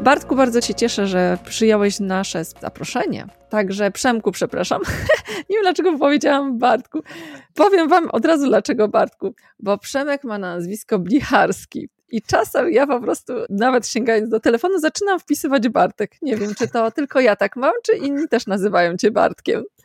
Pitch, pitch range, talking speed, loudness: 235 Hz, 210-290 Hz, 160 wpm, -18 LUFS